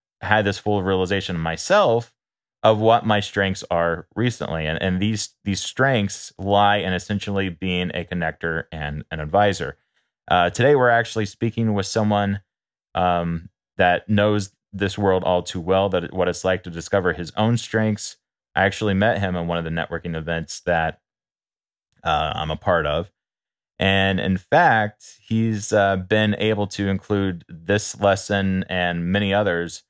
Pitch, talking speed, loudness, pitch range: 100 Hz, 160 wpm, -21 LUFS, 90-105 Hz